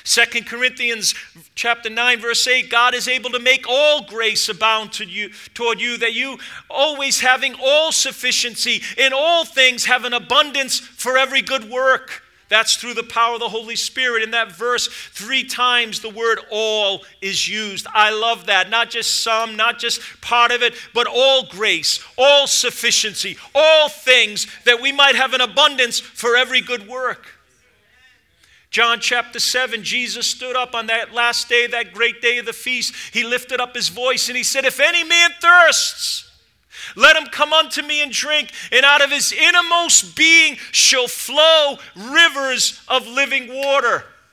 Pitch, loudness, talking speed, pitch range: 245 Hz, -15 LUFS, 170 wpm, 230-270 Hz